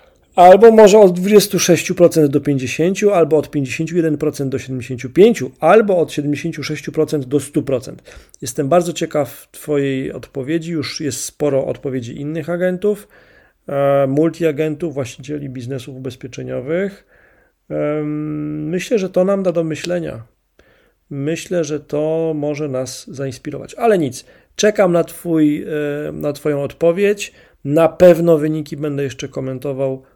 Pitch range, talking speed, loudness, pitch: 140-170 Hz, 115 wpm, -16 LUFS, 150 Hz